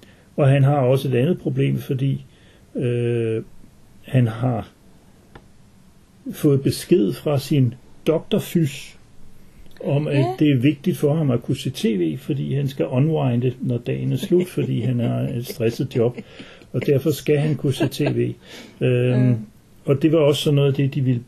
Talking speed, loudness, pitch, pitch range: 170 wpm, -21 LUFS, 140 Hz, 120-150 Hz